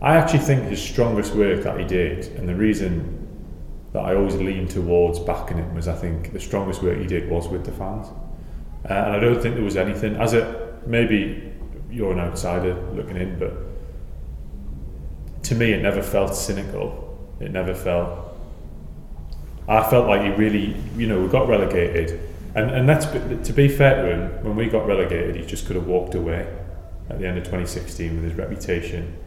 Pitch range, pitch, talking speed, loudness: 85-105 Hz, 90 Hz, 190 wpm, -22 LUFS